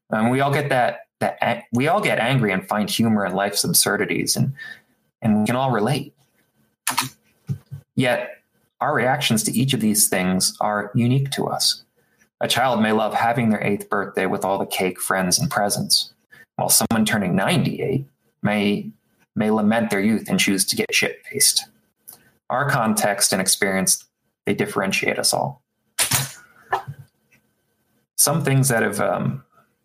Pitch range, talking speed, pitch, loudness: 105-135 Hz, 155 wpm, 115 Hz, -20 LUFS